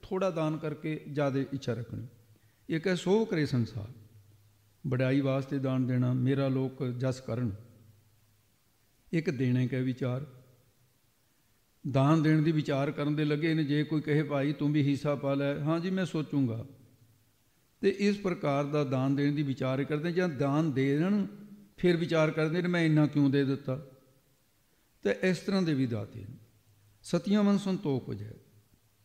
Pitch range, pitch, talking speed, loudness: 120-155 Hz, 140 Hz, 155 wpm, -30 LUFS